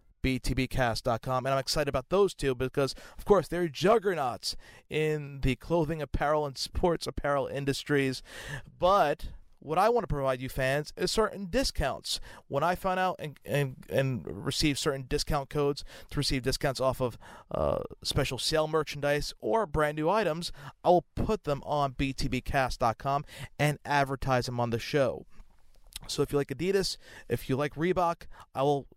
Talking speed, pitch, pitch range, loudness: 160 wpm, 140 Hz, 130-155 Hz, -30 LUFS